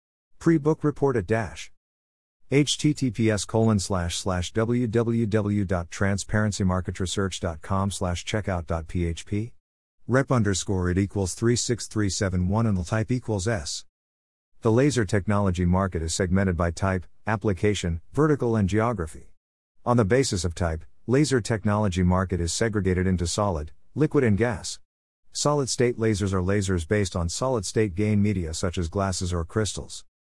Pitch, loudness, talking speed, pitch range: 100 Hz, -25 LUFS, 125 wpm, 90-115 Hz